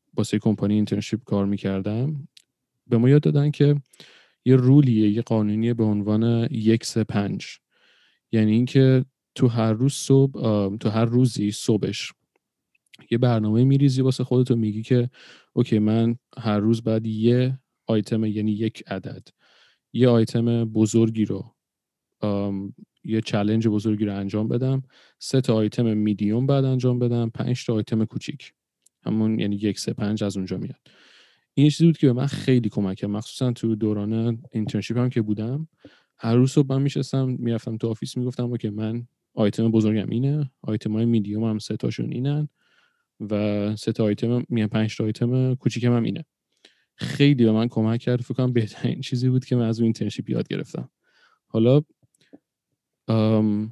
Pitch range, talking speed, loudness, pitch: 110-125 Hz, 160 wpm, -23 LUFS, 115 Hz